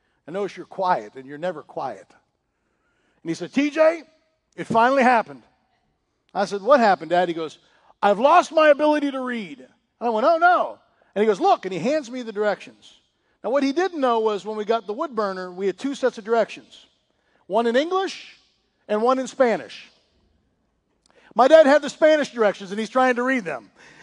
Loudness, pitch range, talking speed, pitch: -21 LUFS, 200-295 Hz, 195 wpm, 235 Hz